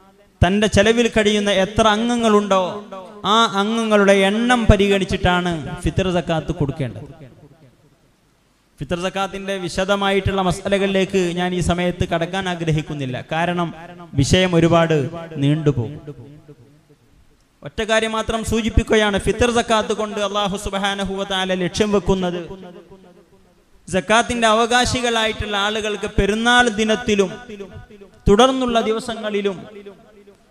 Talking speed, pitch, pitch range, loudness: 85 wpm, 195 Hz, 175-215 Hz, -18 LUFS